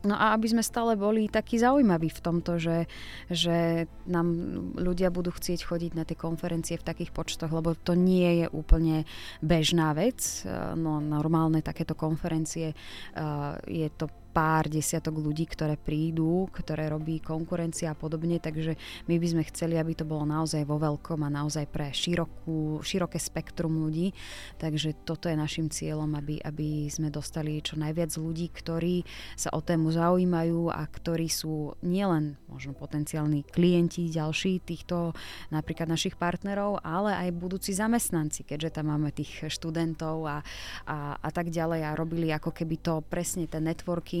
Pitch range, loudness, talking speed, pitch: 155-170 Hz, -29 LUFS, 155 wpm, 160 Hz